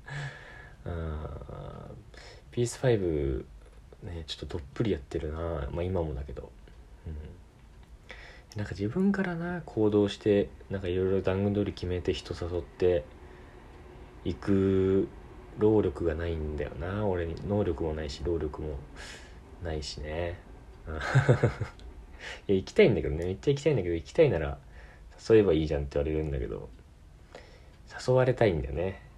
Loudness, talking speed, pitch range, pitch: -29 LUFS, 285 characters per minute, 75-100 Hz, 85 Hz